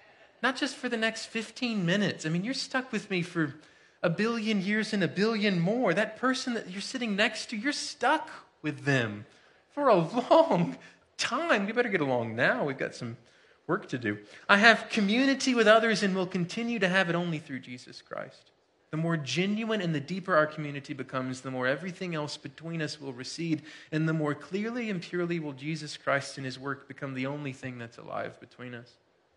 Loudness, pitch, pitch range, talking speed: -29 LUFS, 180 Hz, 145-225 Hz, 200 wpm